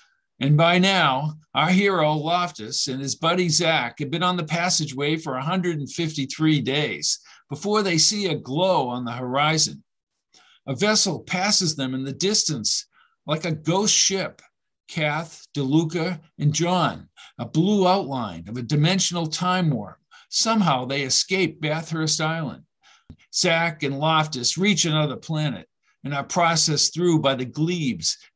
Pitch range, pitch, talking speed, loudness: 145-180 Hz, 160 Hz, 140 wpm, -22 LUFS